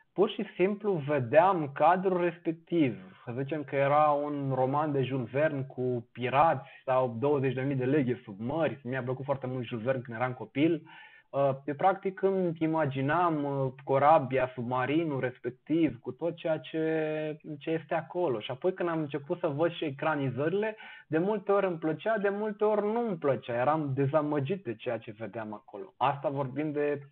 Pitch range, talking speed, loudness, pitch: 130-170 Hz, 170 wpm, -30 LUFS, 150 Hz